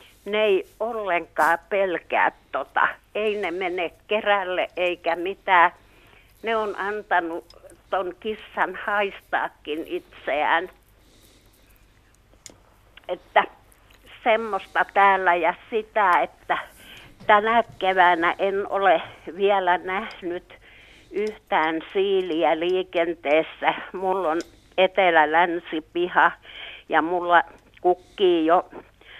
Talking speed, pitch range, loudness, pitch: 80 wpm, 165-210 Hz, -23 LUFS, 180 Hz